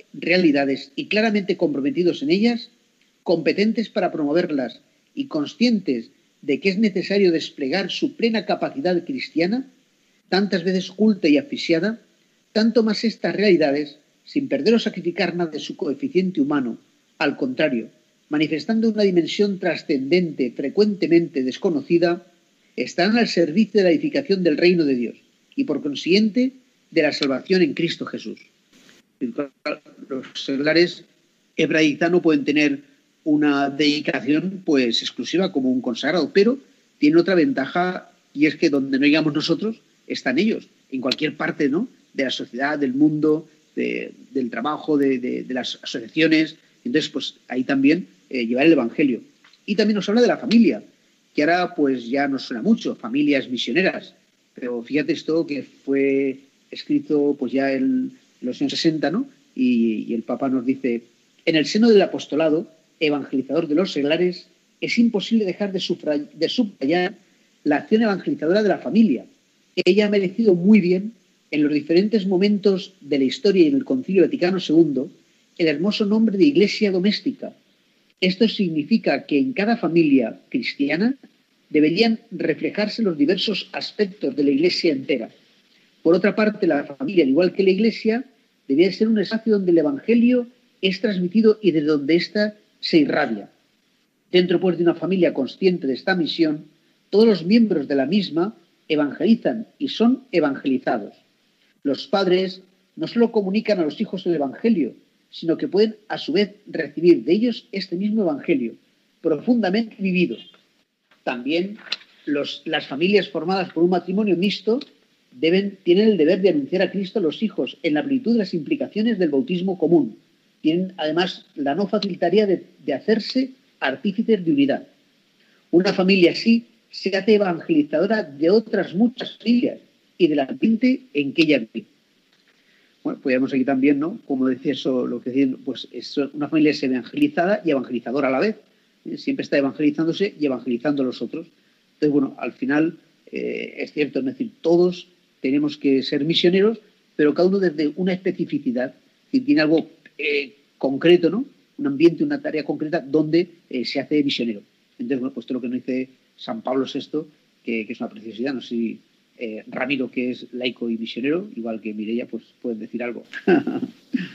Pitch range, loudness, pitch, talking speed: 150-225 Hz, -21 LUFS, 180 Hz, 160 wpm